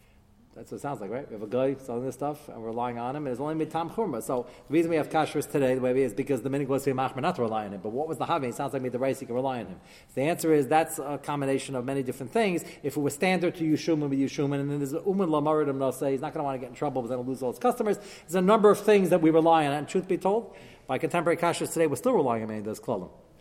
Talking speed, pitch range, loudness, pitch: 335 wpm, 130-165 Hz, -27 LUFS, 145 Hz